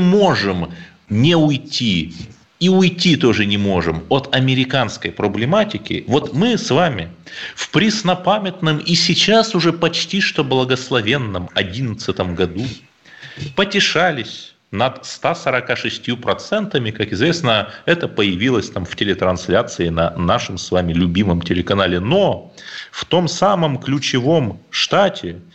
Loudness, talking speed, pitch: -17 LUFS, 115 wpm, 130 Hz